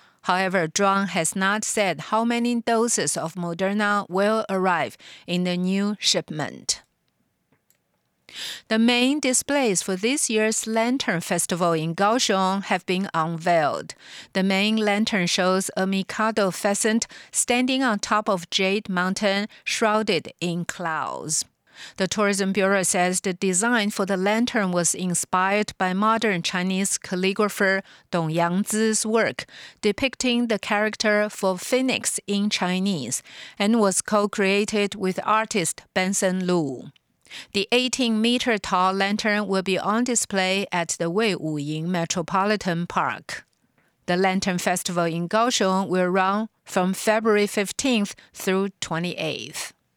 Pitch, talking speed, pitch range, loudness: 195 Hz, 125 wpm, 185-215 Hz, -23 LUFS